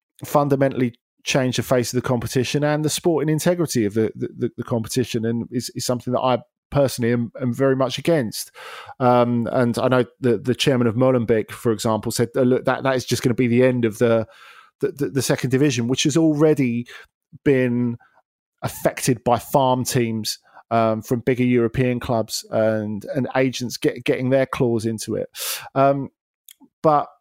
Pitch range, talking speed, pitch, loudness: 120-135 Hz, 180 wpm, 125 Hz, -21 LUFS